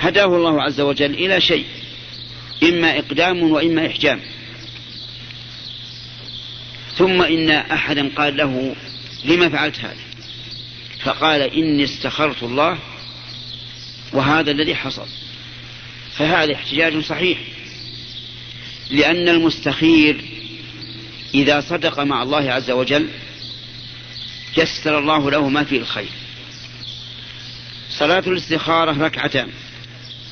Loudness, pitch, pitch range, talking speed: -17 LUFS, 130 Hz, 120-155 Hz, 90 wpm